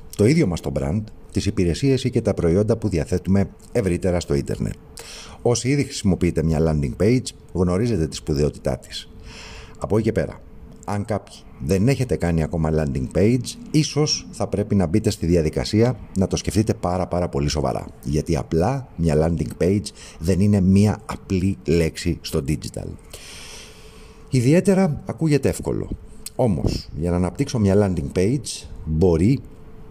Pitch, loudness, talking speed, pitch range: 95 Hz, -21 LUFS, 150 wpm, 80-110 Hz